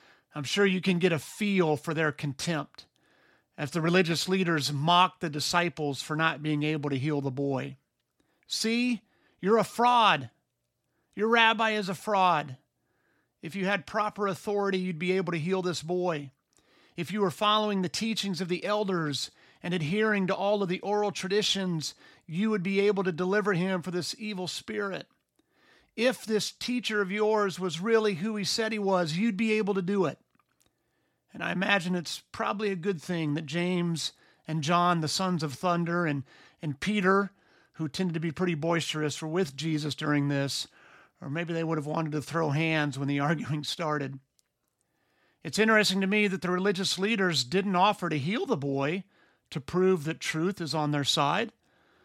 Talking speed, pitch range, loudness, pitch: 180 wpm, 155-200 Hz, -28 LUFS, 180 Hz